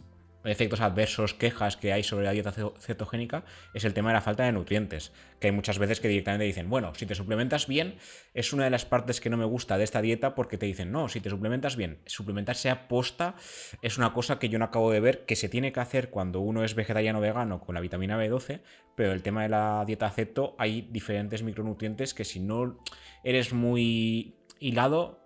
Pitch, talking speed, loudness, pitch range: 110 Hz, 220 wpm, -29 LUFS, 105-120 Hz